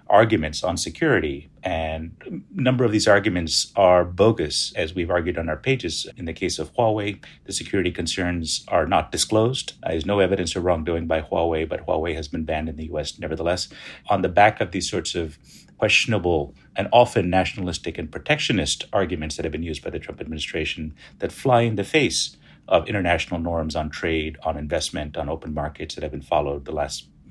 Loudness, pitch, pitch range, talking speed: -23 LUFS, 85 Hz, 80-95 Hz, 190 wpm